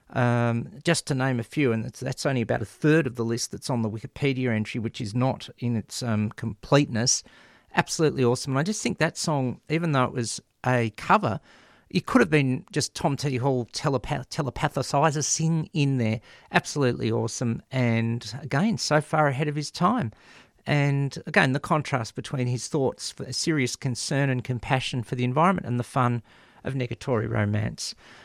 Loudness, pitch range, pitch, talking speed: -26 LUFS, 120-150 Hz, 130 Hz, 185 wpm